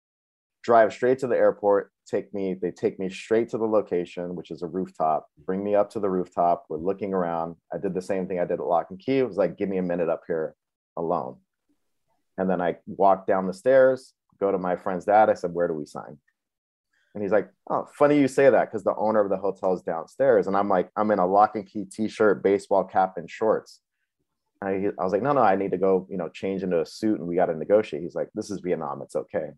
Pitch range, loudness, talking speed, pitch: 90-105 Hz, -25 LUFS, 255 wpm, 95 Hz